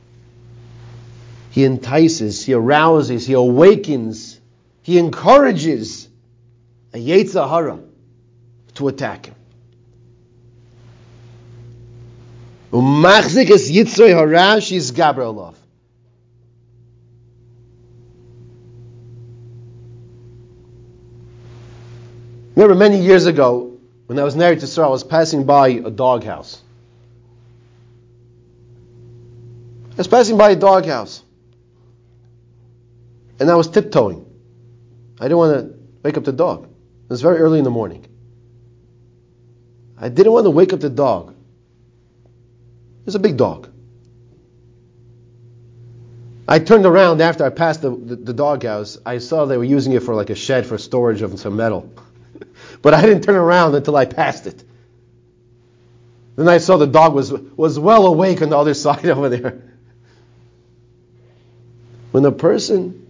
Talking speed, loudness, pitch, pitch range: 115 wpm, -14 LUFS, 120 Hz, 120-145 Hz